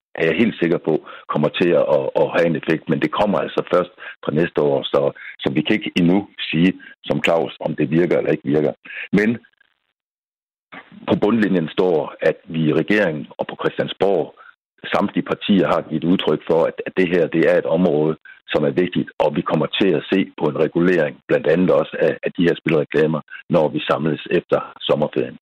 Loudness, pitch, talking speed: -19 LUFS, 395 Hz, 190 wpm